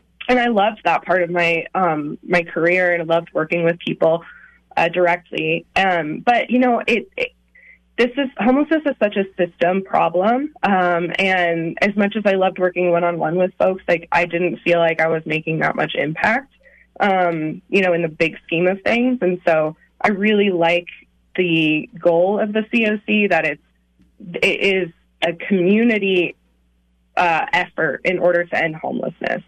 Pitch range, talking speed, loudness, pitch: 170-205 Hz, 185 wpm, -18 LUFS, 180 Hz